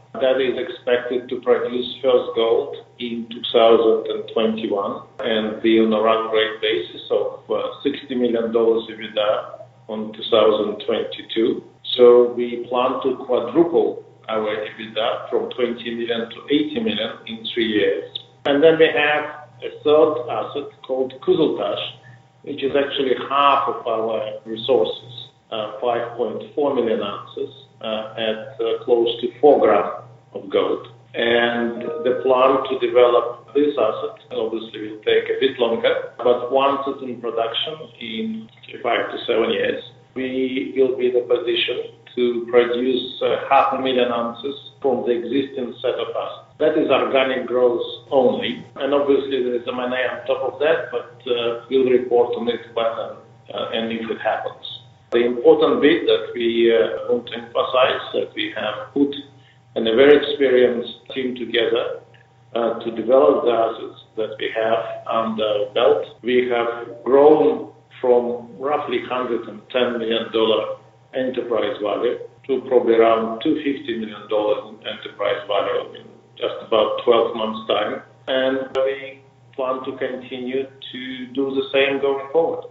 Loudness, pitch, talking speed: -20 LUFS, 130 Hz, 145 wpm